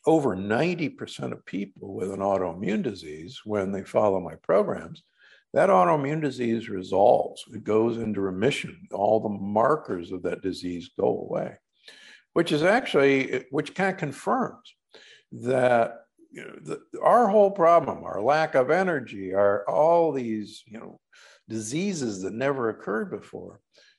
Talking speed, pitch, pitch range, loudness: 145 wpm, 115 Hz, 100-155 Hz, -25 LUFS